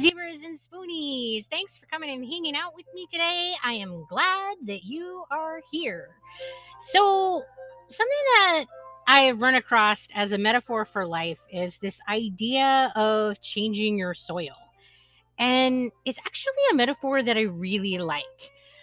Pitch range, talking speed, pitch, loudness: 210-330 Hz, 150 wpm, 260 Hz, -24 LUFS